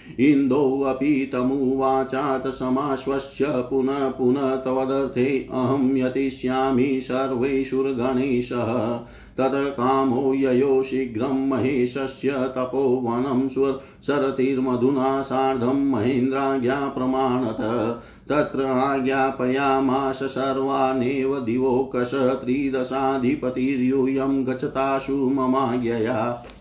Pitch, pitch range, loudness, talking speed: 135 Hz, 130-135 Hz, -22 LUFS, 60 wpm